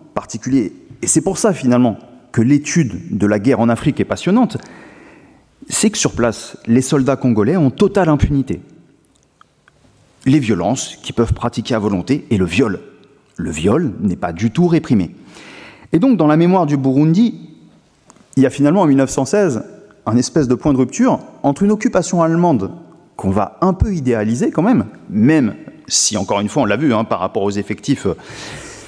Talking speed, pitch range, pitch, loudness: 180 wpm, 115-170 Hz, 140 Hz, -16 LUFS